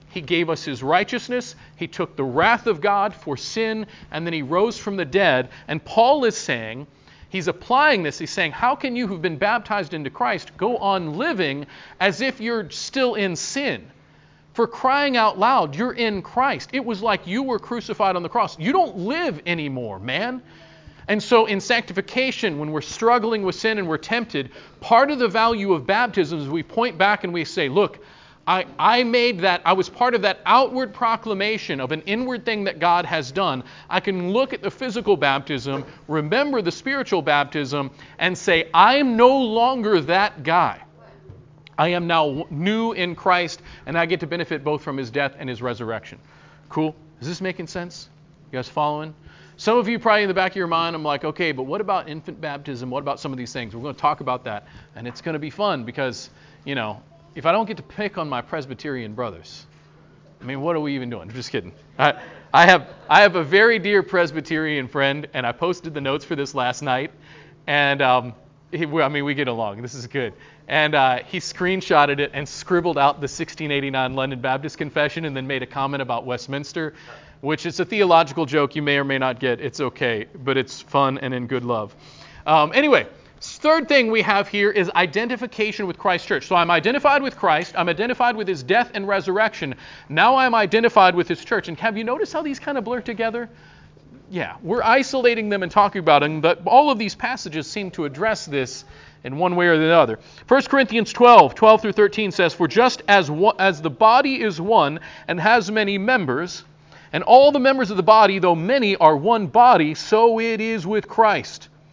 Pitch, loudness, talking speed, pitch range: 175 Hz, -20 LUFS, 205 wpm, 145-220 Hz